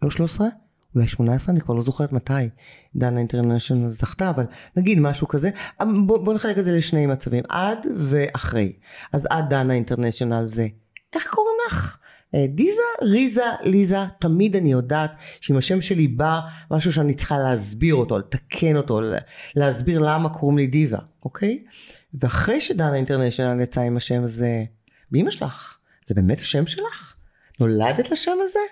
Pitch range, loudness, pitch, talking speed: 125-190 Hz, -22 LUFS, 150 Hz, 150 wpm